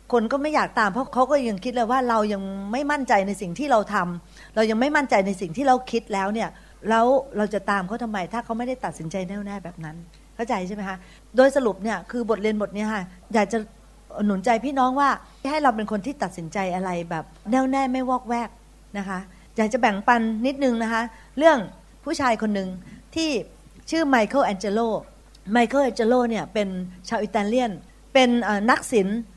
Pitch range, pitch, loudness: 200-255 Hz, 225 Hz, -23 LUFS